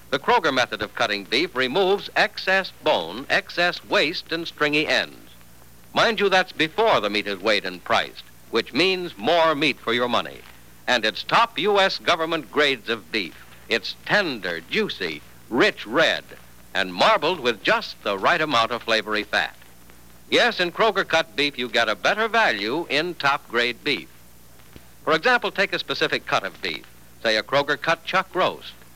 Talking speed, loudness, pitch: 170 wpm, -22 LUFS, 135 Hz